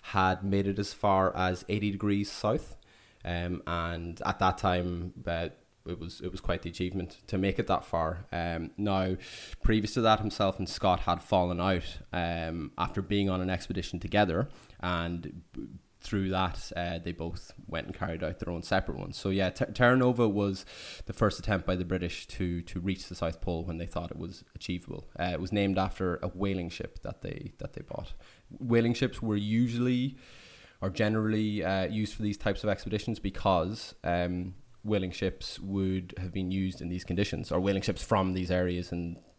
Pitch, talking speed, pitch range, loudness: 95 Hz, 195 wpm, 90-105 Hz, -31 LUFS